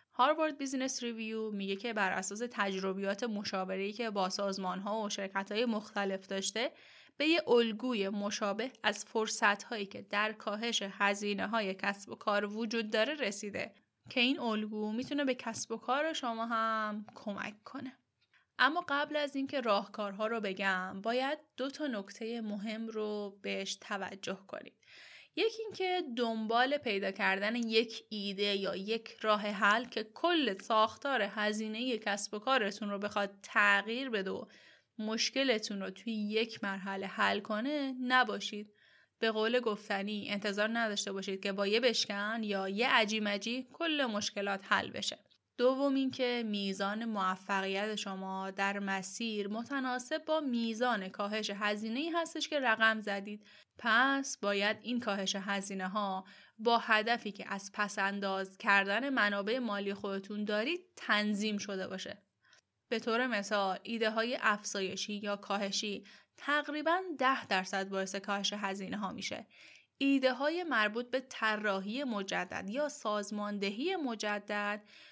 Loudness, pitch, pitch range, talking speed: -34 LUFS, 215 Hz, 200-245 Hz, 140 wpm